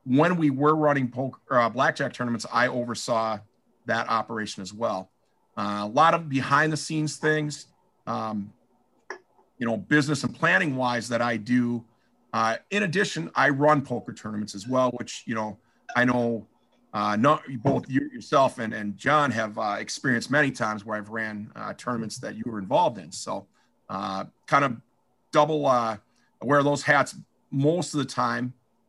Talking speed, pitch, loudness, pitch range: 160 wpm, 125 Hz, -25 LUFS, 110-145 Hz